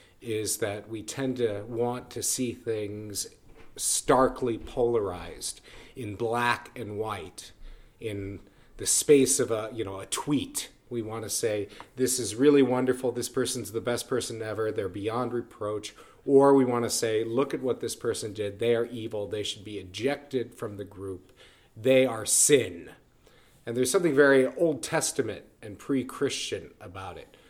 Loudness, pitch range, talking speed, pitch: -27 LUFS, 105-130 Hz, 165 wpm, 115 Hz